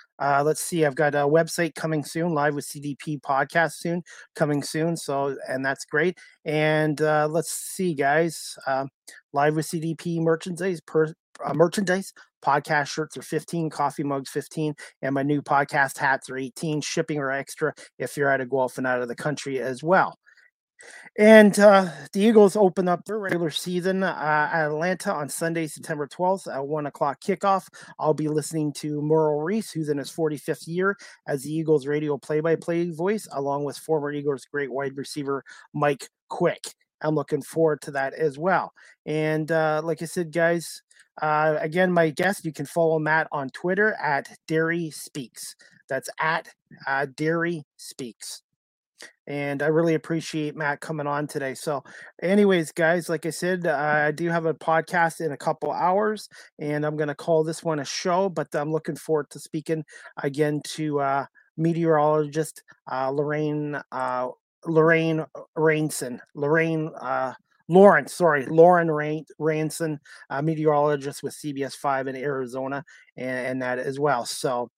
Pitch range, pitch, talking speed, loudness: 145-165 Hz, 155 Hz, 165 wpm, -24 LUFS